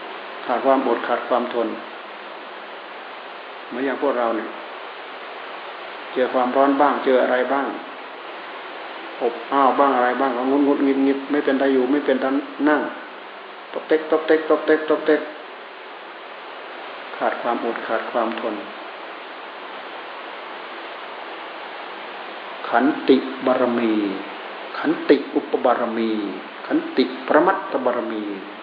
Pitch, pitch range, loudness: 135 Hz, 120-145 Hz, -21 LUFS